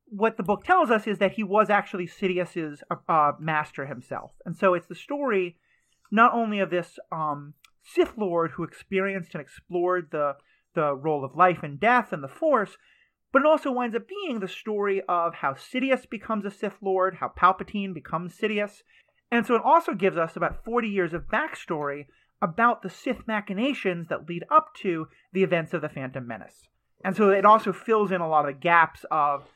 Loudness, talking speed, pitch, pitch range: -25 LUFS, 195 wpm, 190 Hz, 165-220 Hz